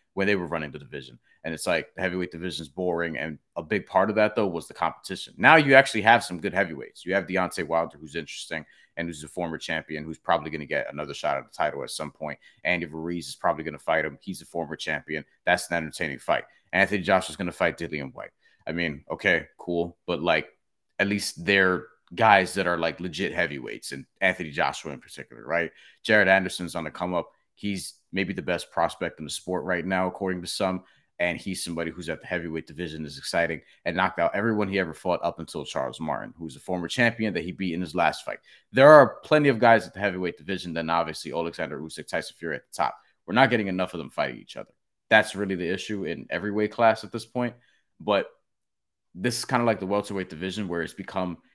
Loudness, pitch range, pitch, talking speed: -26 LUFS, 85-100 Hz, 90 Hz, 235 wpm